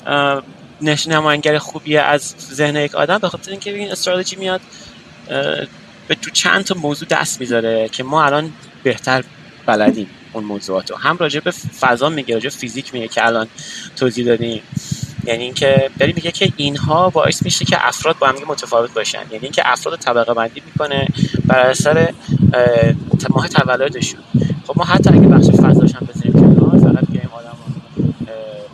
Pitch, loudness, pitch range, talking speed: 145 Hz, -15 LUFS, 120-160 Hz, 145 wpm